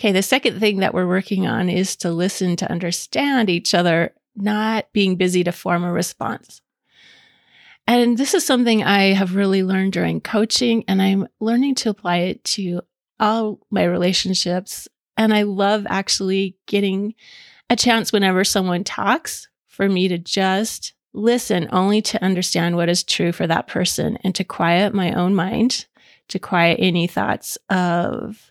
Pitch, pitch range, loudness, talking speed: 195 Hz, 180-215 Hz, -19 LUFS, 160 wpm